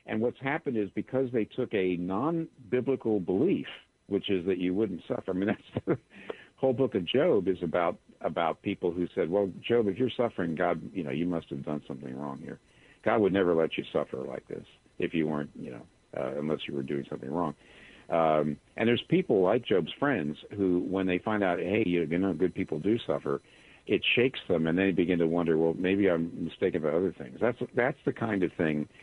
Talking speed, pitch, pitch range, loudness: 215 wpm, 95 Hz, 80-110 Hz, -29 LUFS